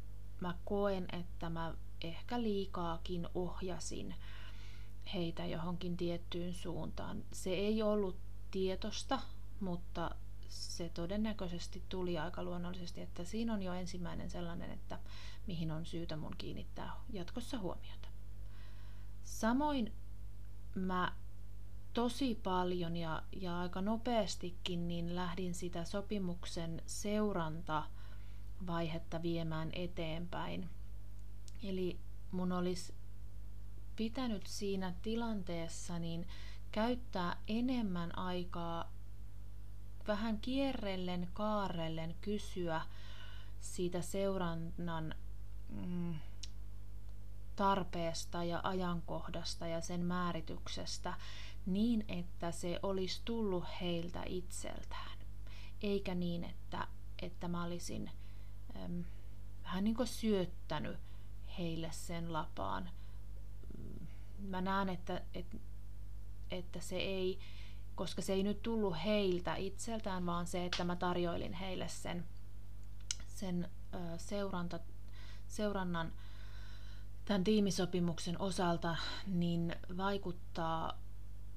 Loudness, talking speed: -41 LUFS, 90 wpm